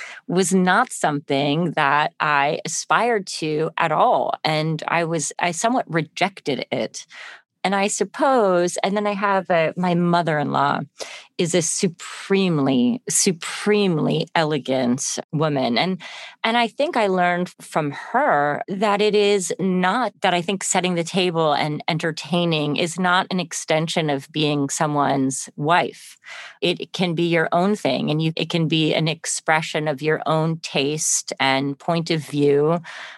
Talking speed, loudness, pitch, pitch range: 145 wpm, -21 LUFS, 170 Hz, 155-190 Hz